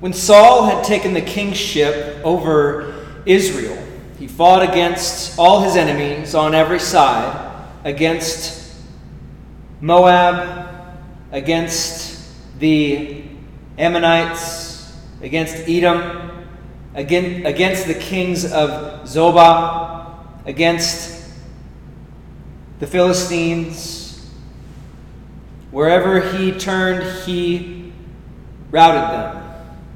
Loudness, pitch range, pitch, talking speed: -15 LUFS, 155-180 Hz, 165 Hz, 75 wpm